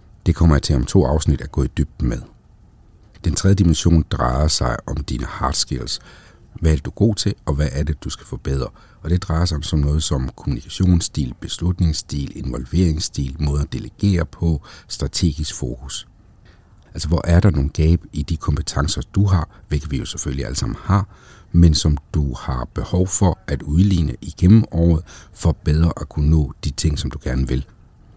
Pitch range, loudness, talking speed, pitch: 75-90 Hz, -20 LUFS, 190 wpm, 80 Hz